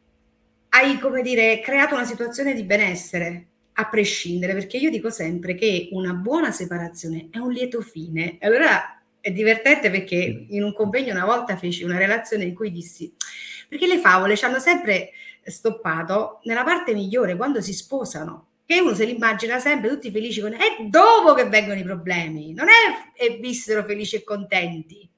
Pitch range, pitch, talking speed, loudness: 180-250 Hz, 215 Hz, 175 wpm, -20 LUFS